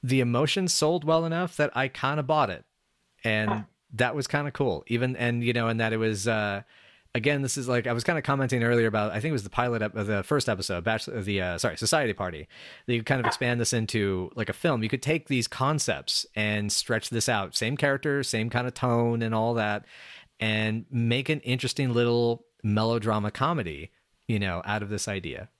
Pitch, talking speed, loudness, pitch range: 120 Hz, 225 wpm, -27 LUFS, 110-135 Hz